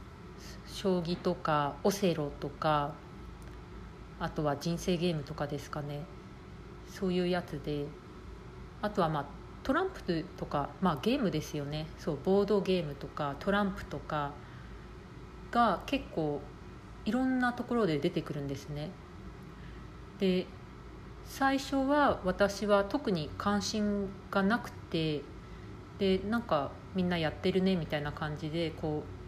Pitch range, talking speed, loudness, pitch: 150-200 Hz, 245 characters per minute, -33 LUFS, 170 Hz